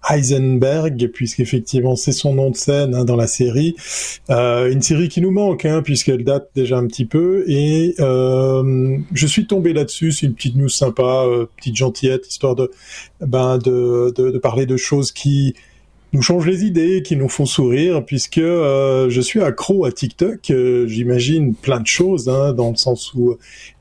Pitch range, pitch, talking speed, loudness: 125-155 Hz, 135 Hz, 180 wpm, -16 LUFS